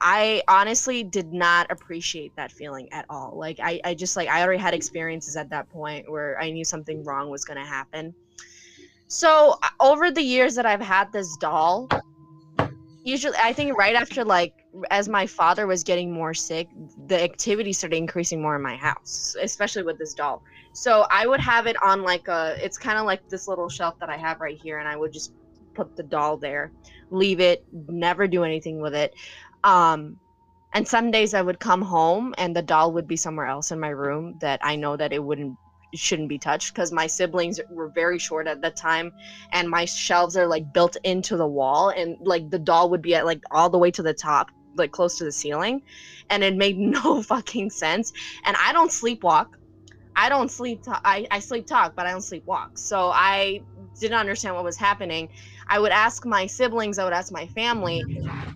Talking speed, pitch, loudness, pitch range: 205 wpm, 175 Hz, -23 LUFS, 160-200 Hz